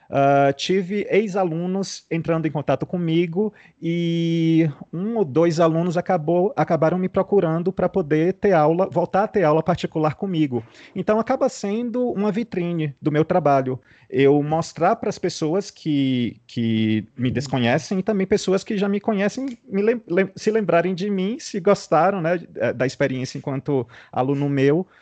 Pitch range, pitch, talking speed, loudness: 150-195 Hz, 170 Hz, 155 wpm, -21 LUFS